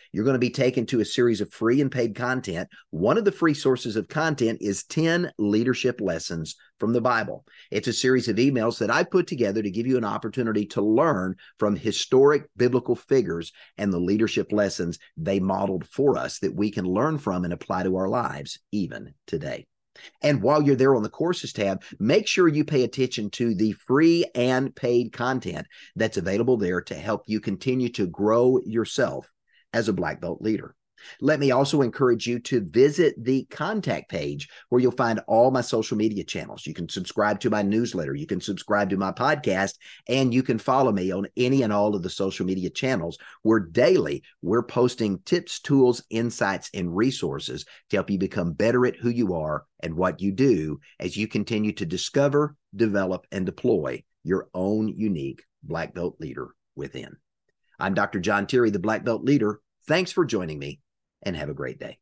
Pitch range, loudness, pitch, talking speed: 100-130 Hz, -24 LUFS, 115 Hz, 195 wpm